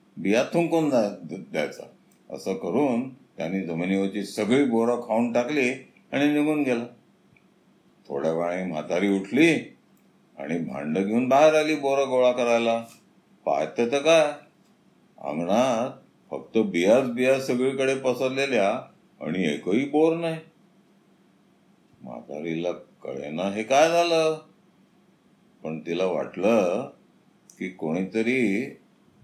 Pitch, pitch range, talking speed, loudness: 125 Hz, 100-150 Hz, 100 wpm, -24 LUFS